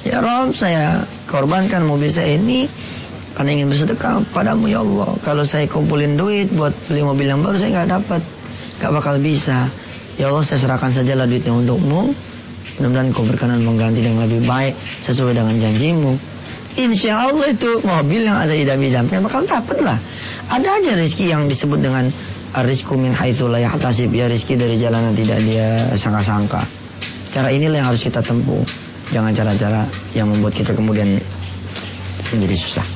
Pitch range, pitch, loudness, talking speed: 115-155 Hz, 130 Hz, -17 LUFS, 155 wpm